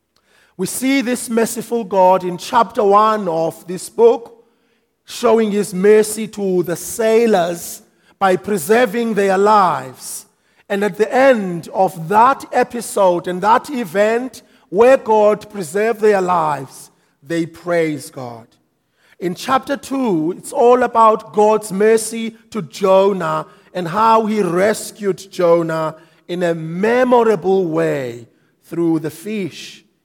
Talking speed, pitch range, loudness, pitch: 120 wpm, 175-230 Hz, -16 LUFS, 205 Hz